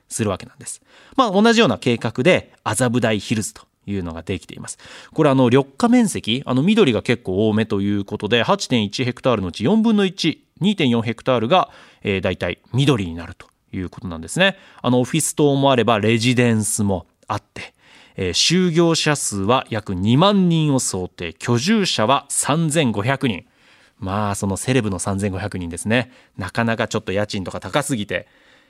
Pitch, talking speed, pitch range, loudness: 120 Hz, 330 characters per minute, 100-145 Hz, -19 LUFS